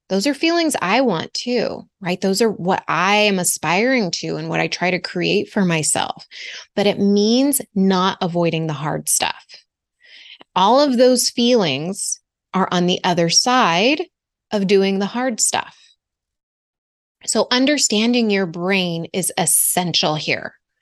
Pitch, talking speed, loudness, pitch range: 200 Hz, 145 wpm, -17 LUFS, 180-245 Hz